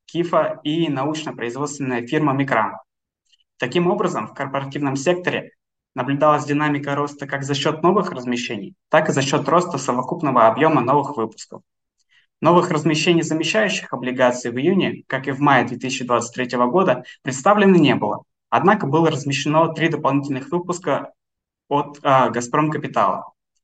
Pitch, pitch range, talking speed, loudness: 145 Hz, 130-160 Hz, 130 wpm, -19 LUFS